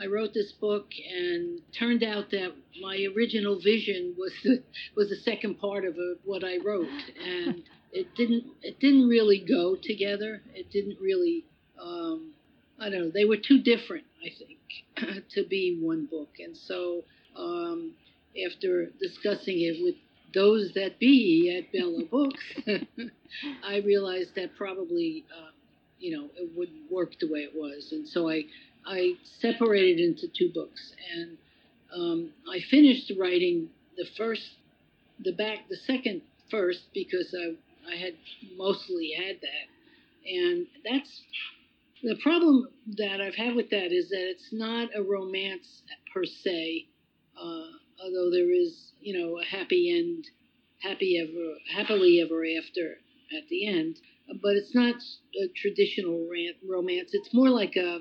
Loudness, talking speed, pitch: -28 LUFS, 150 wpm, 235 Hz